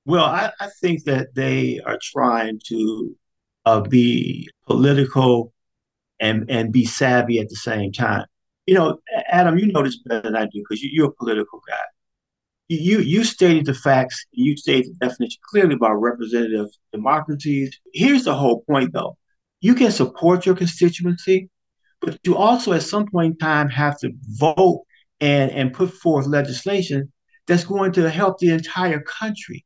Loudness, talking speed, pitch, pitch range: -19 LUFS, 165 wpm, 145 Hz, 120-185 Hz